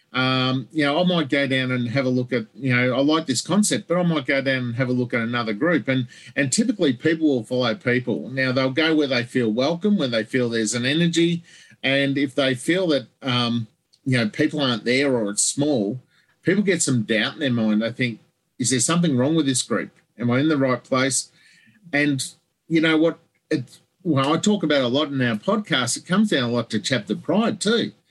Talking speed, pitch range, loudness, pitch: 235 wpm, 125-160 Hz, -21 LUFS, 135 Hz